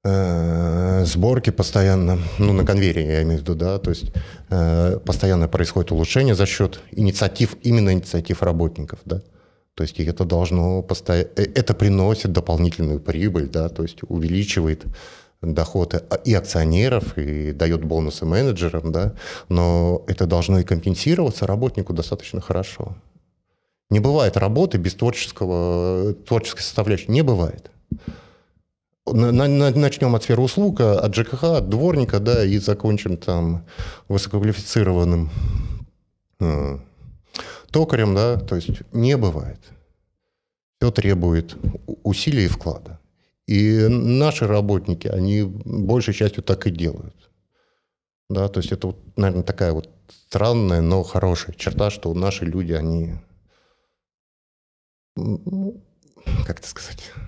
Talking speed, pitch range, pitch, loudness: 115 wpm, 85-110 Hz, 95 Hz, -20 LUFS